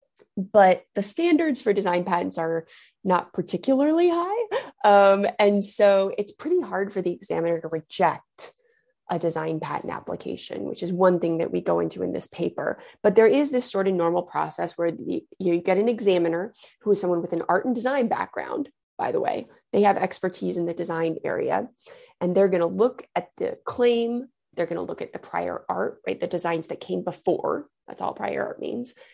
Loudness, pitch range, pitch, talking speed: -24 LUFS, 175-250 Hz, 195 Hz, 200 wpm